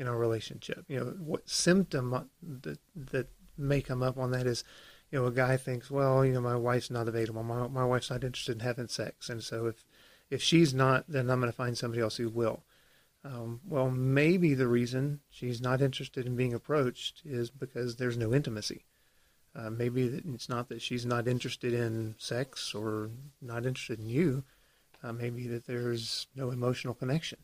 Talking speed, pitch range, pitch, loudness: 190 wpm, 120-135 Hz, 125 Hz, -32 LUFS